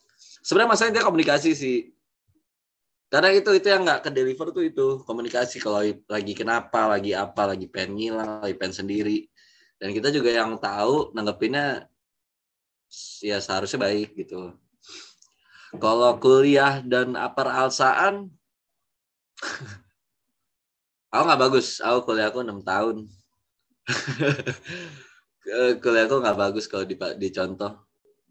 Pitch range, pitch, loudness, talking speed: 105-150 Hz, 120 Hz, -23 LUFS, 115 wpm